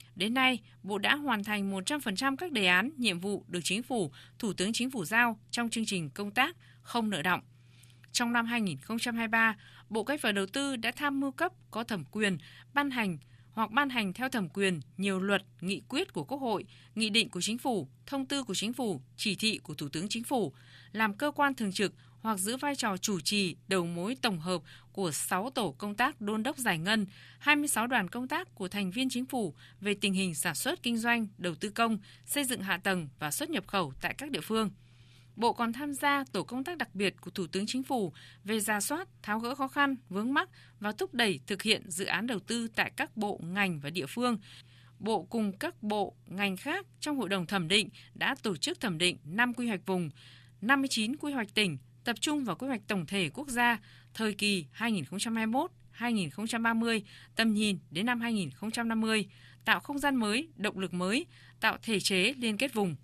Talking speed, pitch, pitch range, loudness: 210 wpm, 215 Hz, 185-245 Hz, -31 LUFS